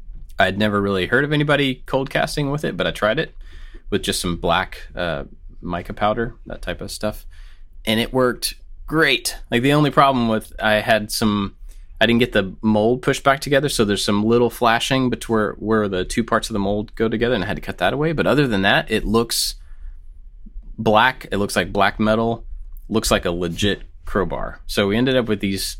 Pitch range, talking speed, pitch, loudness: 95-120 Hz, 210 wpm, 110 Hz, -20 LUFS